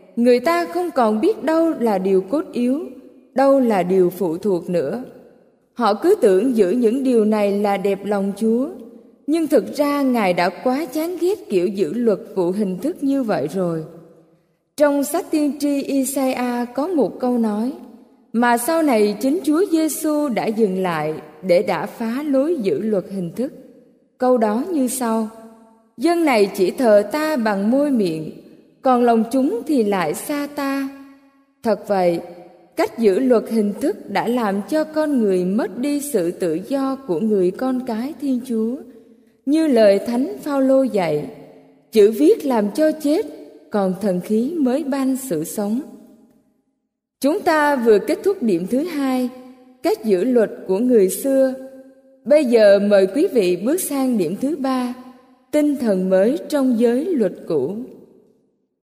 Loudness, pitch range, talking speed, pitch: -19 LUFS, 205-275 Hz, 165 wpm, 245 Hz